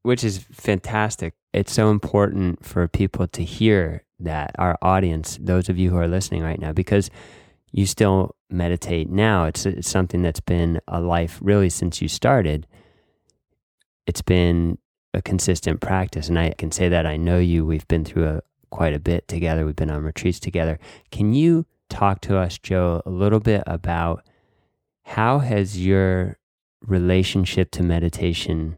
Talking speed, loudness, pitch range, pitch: 165 wpm, -21 LUFS, 85-100 Hz, 90 Hz